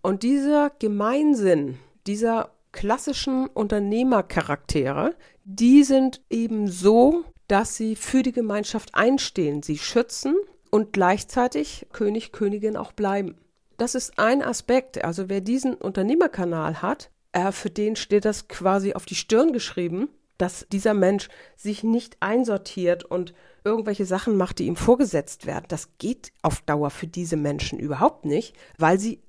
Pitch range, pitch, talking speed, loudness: 185-245 Hz, 210 Hz, 135 wpm, -23 LUFS